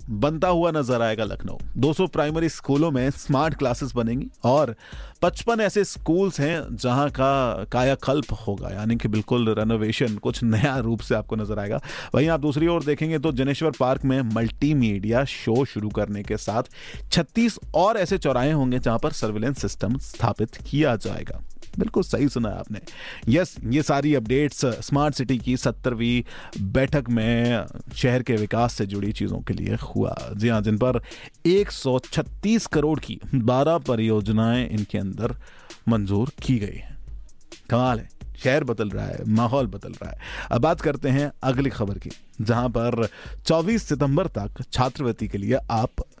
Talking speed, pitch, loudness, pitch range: 155 wpm, 125 Hz, -24 LUFS, 110-145 Hz